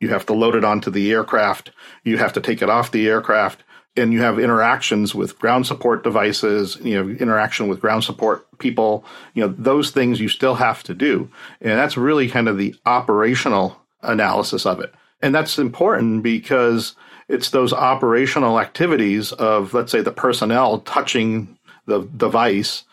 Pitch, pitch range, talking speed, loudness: 110 Hz, 105-120 Hz, 175 wpm, -18 LUFS